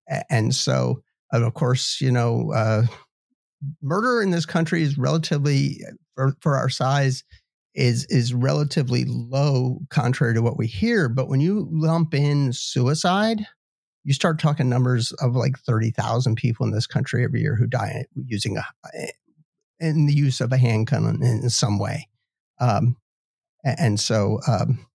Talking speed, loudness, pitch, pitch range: 155 wpm, -22 LUFS, 135 Hz, 120-150 Hz